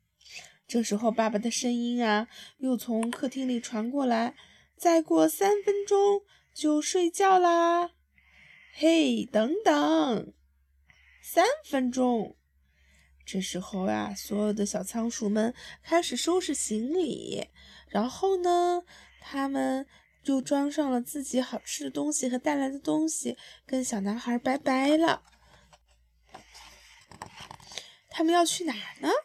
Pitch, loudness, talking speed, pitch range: 260 Hz, -28 LUFS, 175 characters per minute, 220-320 Hz